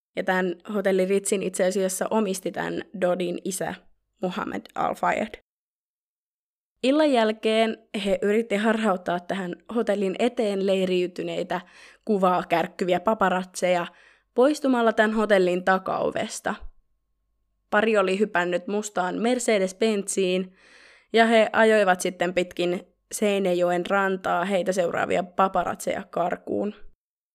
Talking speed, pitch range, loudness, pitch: 95 wpm, 180-220 Hz, -24 LUFS, 190 Hz